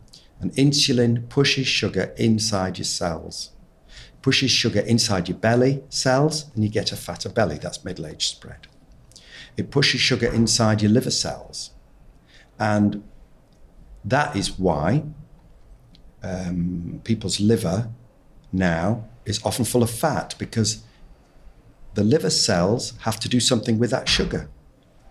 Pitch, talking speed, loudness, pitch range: 115 Hz, 130 wpm, -22 LUFS, 105-130 Hz